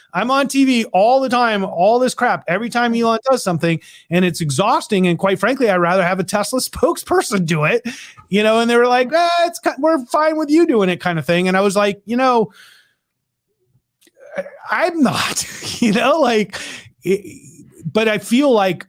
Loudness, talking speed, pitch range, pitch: -16 LUFS, 195 wpm, 185-265 Hz, 225 Hz